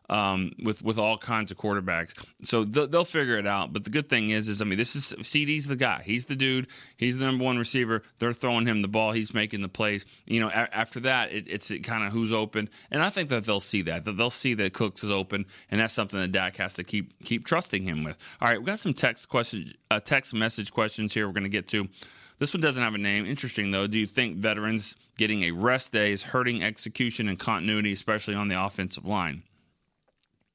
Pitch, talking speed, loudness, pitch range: 110 Hz, 240 wpm, -27 LUFS, 100-120 Hz